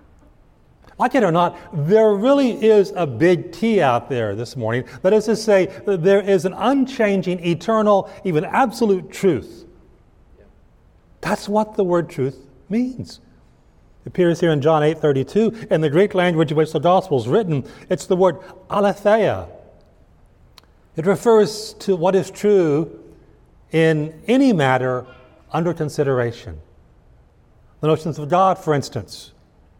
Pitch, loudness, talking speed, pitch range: 180 Hz, -18 LUFS, 145 wpm, 150-205 Hz